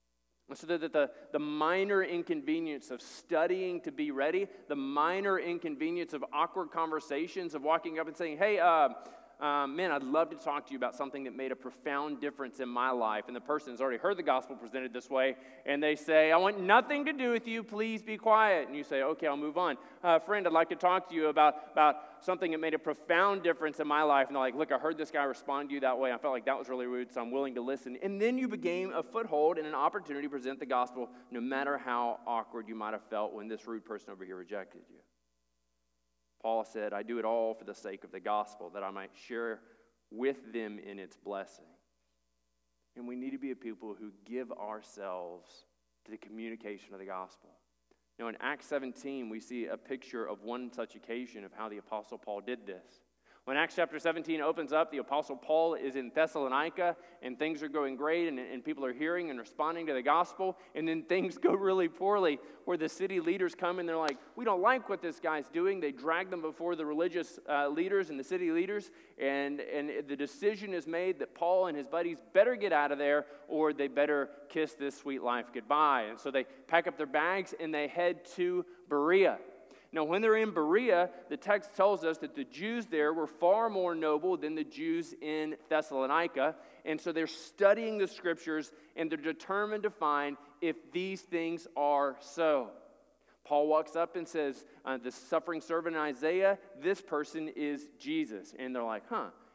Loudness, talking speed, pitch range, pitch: -33 LUFS, 215 wpm, 130-175 Hz, 150 Hz